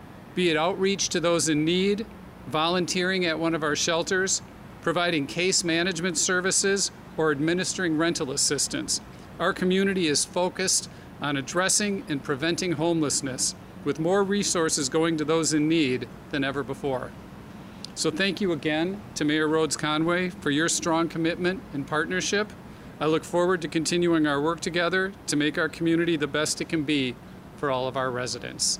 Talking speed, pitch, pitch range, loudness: 160 wpm, 165 Hz, 150-180 Hz, -25 LUFS